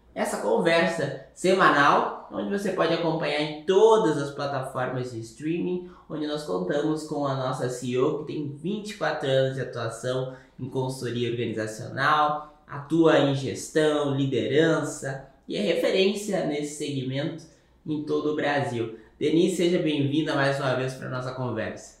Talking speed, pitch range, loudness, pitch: 140 wpm, 130-155 Hz, -26 LUFS, 145 Hz